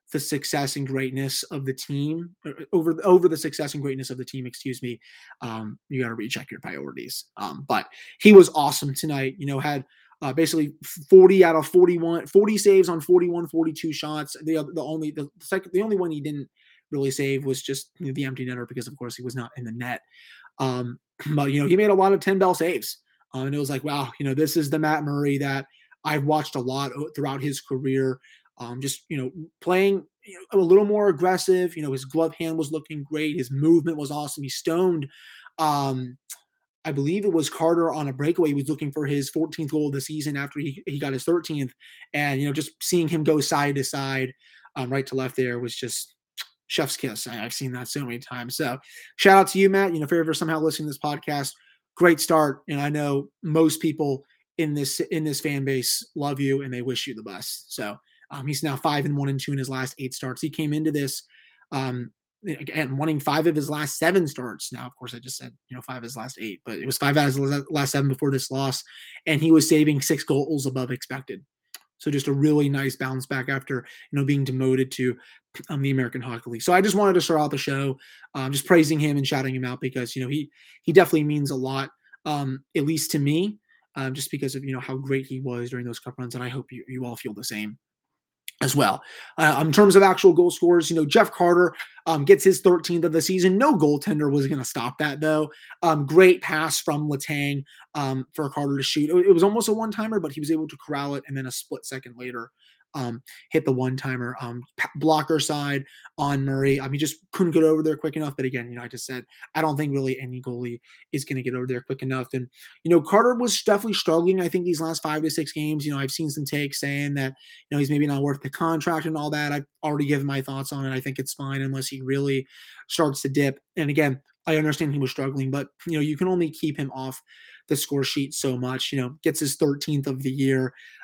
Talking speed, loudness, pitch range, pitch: 240 wpm, -23 LUFS, 135-160 Hz, 145 Hz